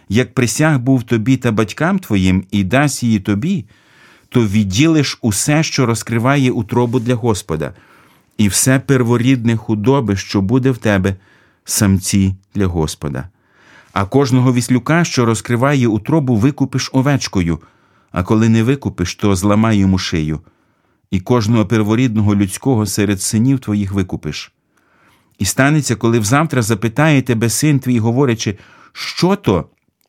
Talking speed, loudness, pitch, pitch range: 130 wpm, -15 LUFS, 115 Hz, 100-130 Hz